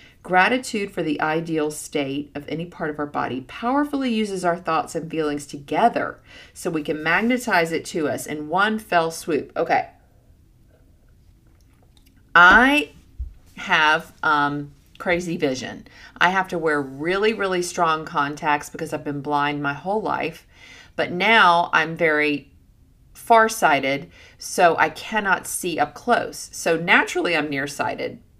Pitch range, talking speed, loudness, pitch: 145-185 Hz, 135 wpm, -21 LUFS, 160 Hz